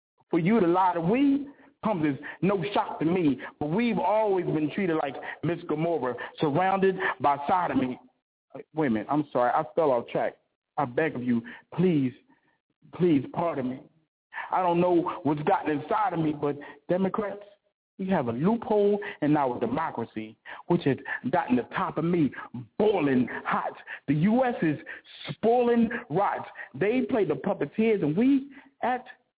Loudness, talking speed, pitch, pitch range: -27 LUFS, 160 wpm, 175 Hz, 150-215 Hz